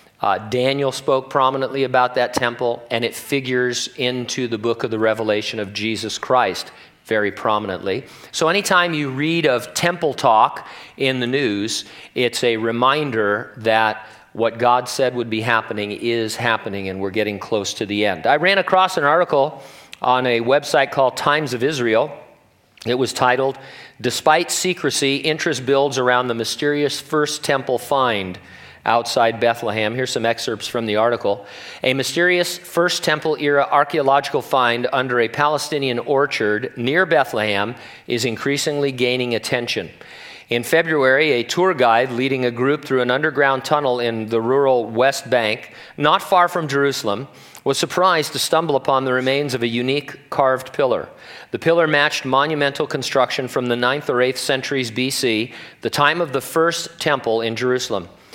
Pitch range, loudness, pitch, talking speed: 115-145 Hz, -19 LUFS, 130 Hz, 155 wpm